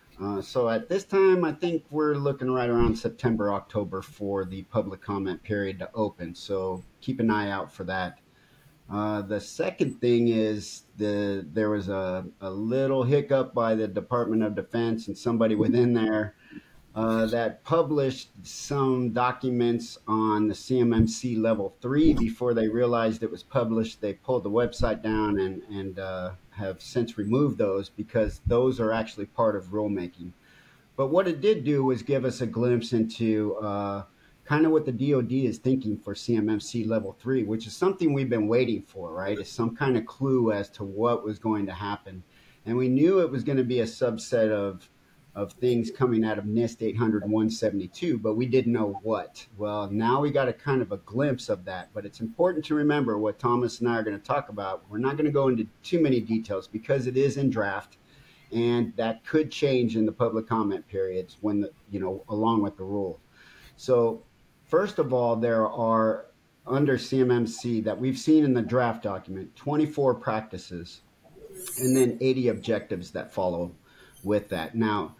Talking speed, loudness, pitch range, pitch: 185 wpm, -27 LUFS, 105-125 Hz, 115 Hz